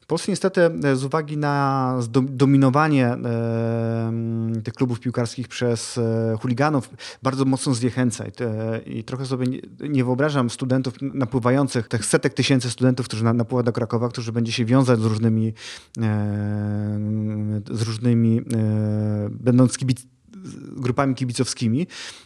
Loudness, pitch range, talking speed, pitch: -22 LUFS, 115-130 Hz, 115 wpm, 125 Hz